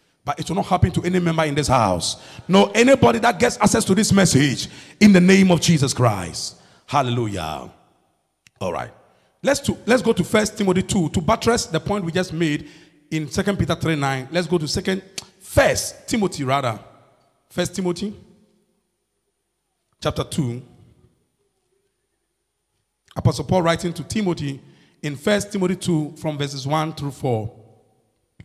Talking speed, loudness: 150 wpm, -20 LUFS